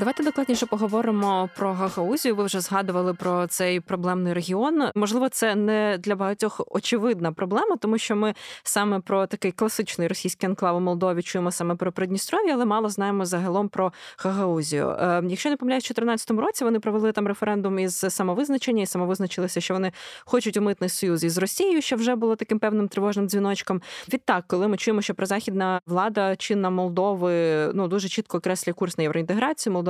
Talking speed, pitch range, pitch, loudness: 175 wpm, 185-220 Hz, 195 Hz, -24 LUFS